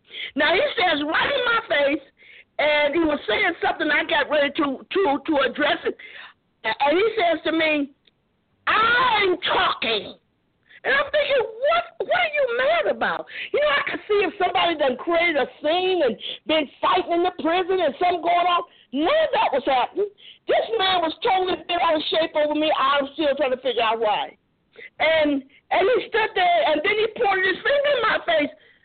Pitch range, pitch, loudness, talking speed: 295-375 Hz, 325 Hz, -21 LUFS, 195 wpm